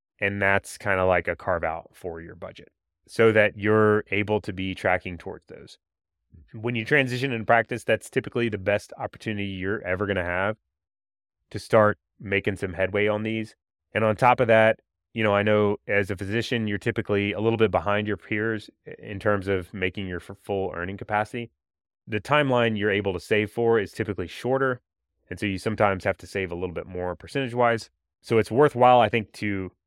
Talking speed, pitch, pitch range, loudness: 200 wpm, 105 Hz, 95-115 Hz, -24 LUFS